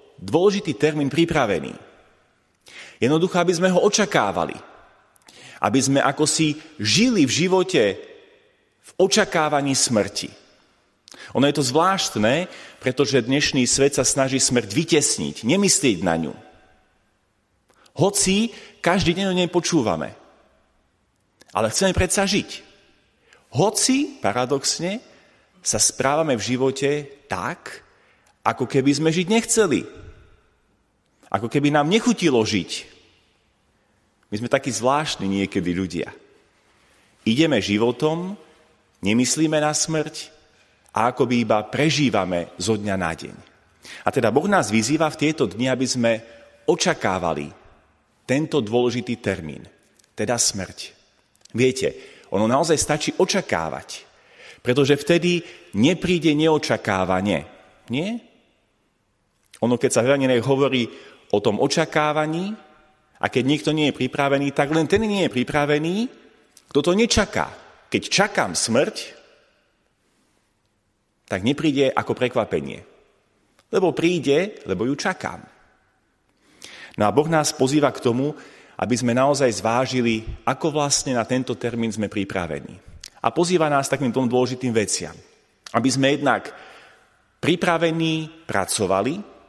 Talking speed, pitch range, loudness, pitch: 115 wpm, 120-170 Hz, -21 LUFS, 145 Hz